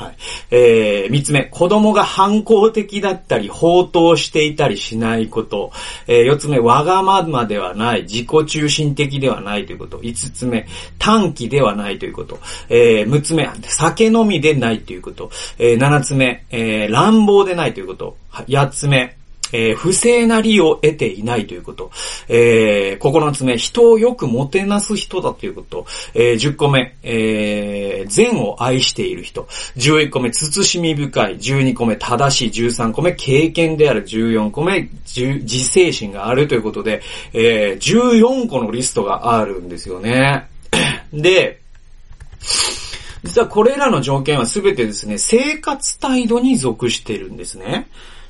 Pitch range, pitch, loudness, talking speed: 115-195 Hz, 140 Hz, -15 LUFS, 285 characters per minute